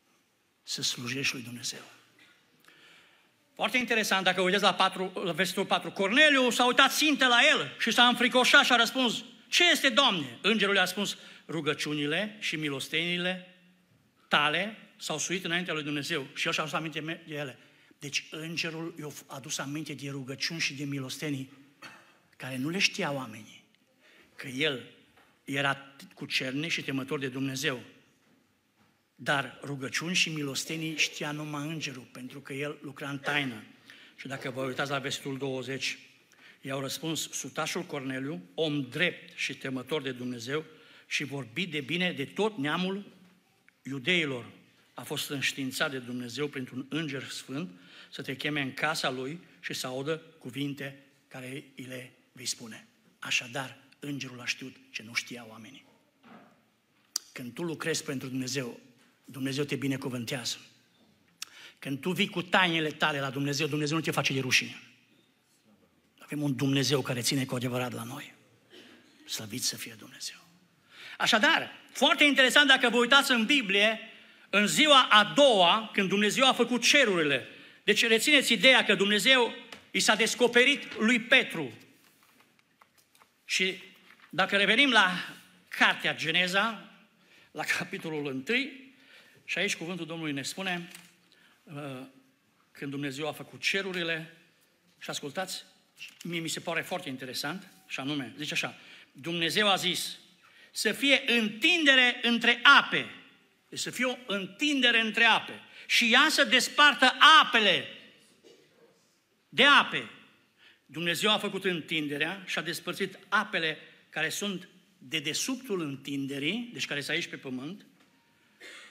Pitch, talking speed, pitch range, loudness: 160 Hz, 140 wpm, 140-205 Hz, -27 LUFS